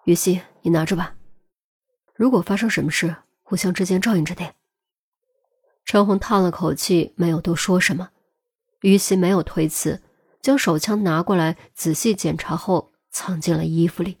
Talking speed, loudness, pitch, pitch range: 235 characters per minute, -20 LUFS, 185 Hz, 170-210 Hz